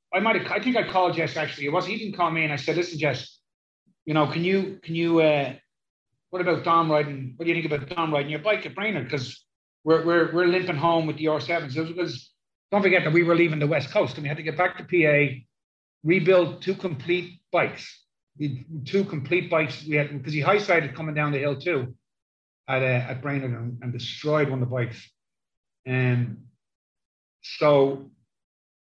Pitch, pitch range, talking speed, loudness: 155 Hz, 130-175 Hz, 215 wpm, -24 LUFS